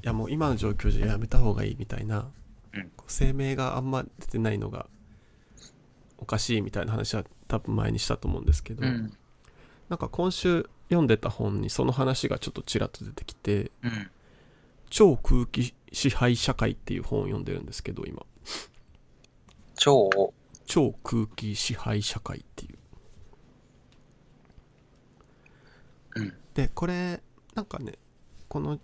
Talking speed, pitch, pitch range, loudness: 265 characters per minute, 115 Hz, 105-130 Hz, -28 LUFS